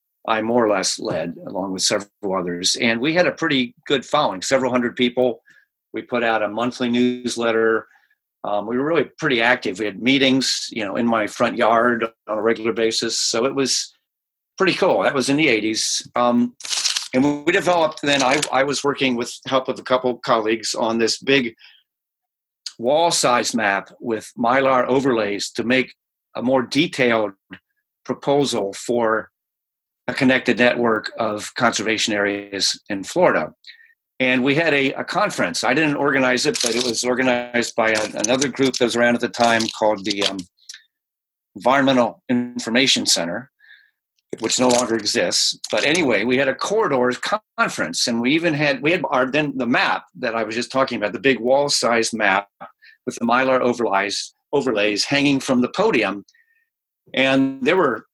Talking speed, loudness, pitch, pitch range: 175 wpm, -19 LUFS, 125 Hz, 115-135 Hz